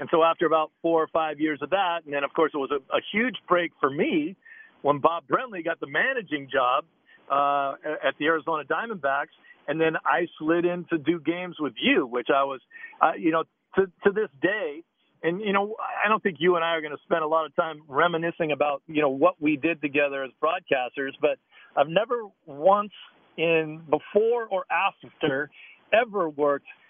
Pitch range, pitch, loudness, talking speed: 150-190 Hz, 165 Hz, -25 LUFS, 205 wpm